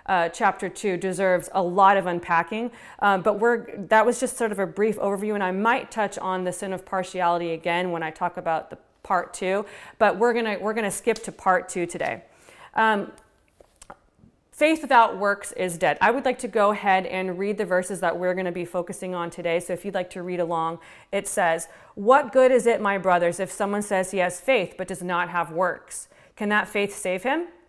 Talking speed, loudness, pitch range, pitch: 215 wpm, -24 LUFS, 180-215 Hz, 195 Hz